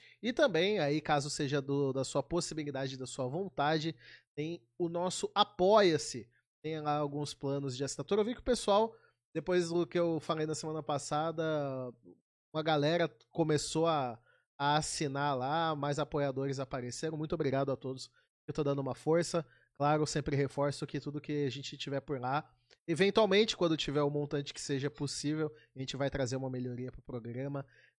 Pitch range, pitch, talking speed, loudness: 140-165 Hz, 150 Hz, 180 wpm, -34 LUFS